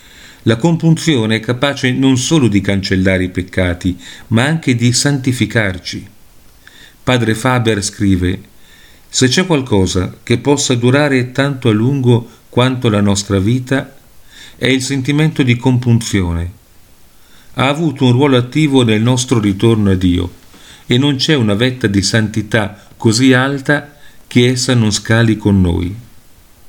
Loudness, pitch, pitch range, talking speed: -13 LUFS, 120 Hz, 100-130 Hz, 135 wpm